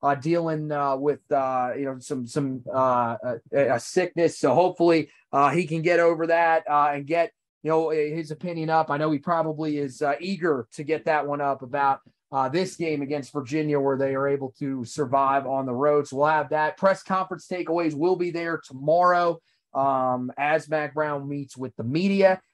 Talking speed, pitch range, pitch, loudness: 200 wpm, 140-165 Hz, 150 Hz, -24 LUFS